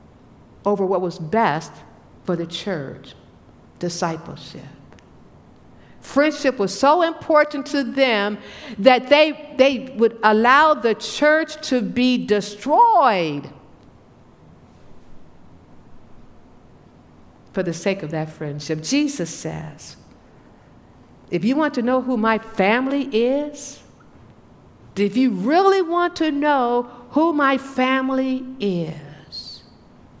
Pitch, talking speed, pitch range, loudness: 245 Hz, 100 wpm, 190-280 Hz, -19 LUFS